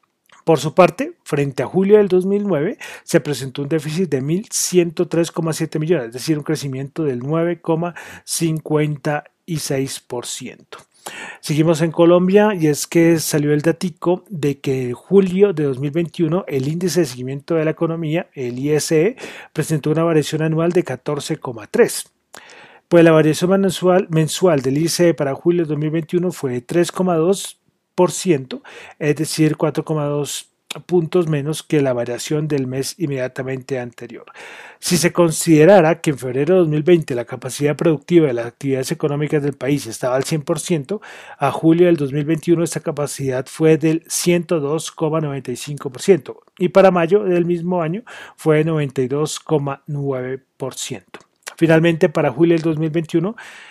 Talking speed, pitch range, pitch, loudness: 135 wpm, 145-175 Hz, 160 Hz, -18 LUFS